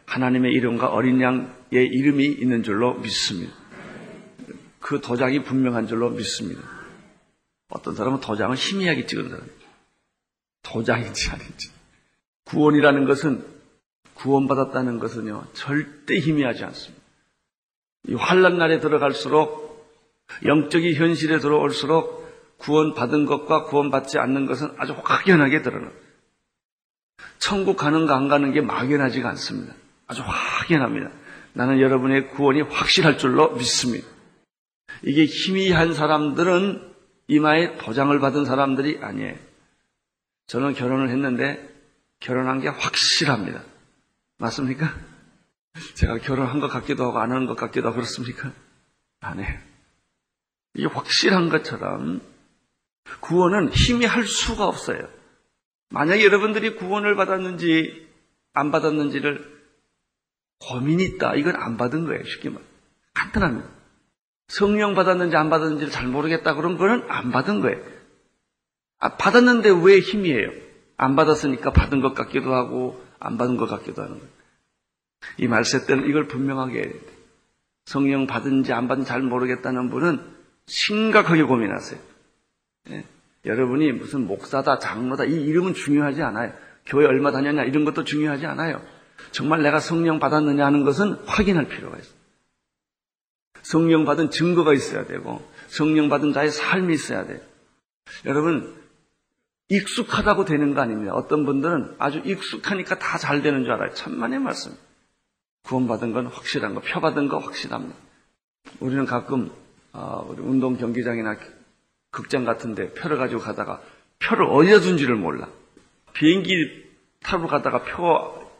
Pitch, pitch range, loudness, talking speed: 145 Hz, 130-165 Hz, -21 LUFS, 305 characters per minute